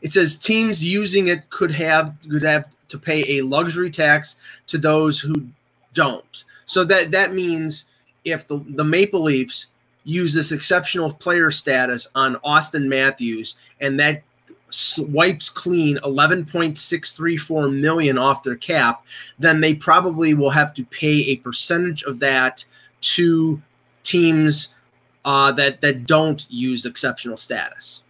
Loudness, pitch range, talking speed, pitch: -18 LUFS, 140-165 Hz, 135 wpm, 150 Hz